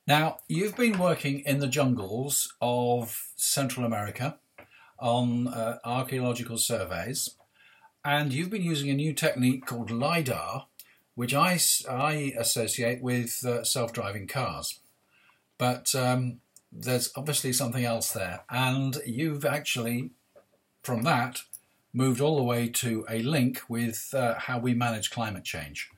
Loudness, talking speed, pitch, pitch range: -28 LUFS, 135 wpm, 125 Hz, 115-140 Hz